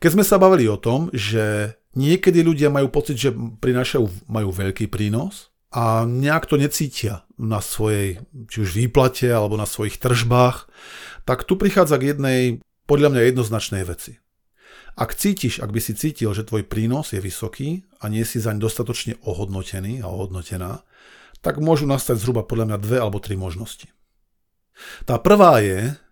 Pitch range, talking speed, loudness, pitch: 105-140 Hz, 165 wpm, -20 LUFS, 115 Hz